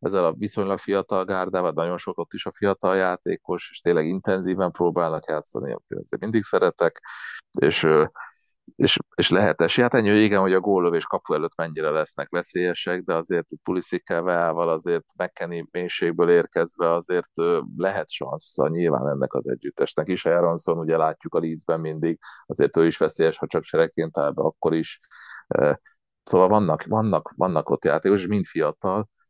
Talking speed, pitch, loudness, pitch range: 160 wpm, 95 Hz, -23 LUFS, 85-105 Hz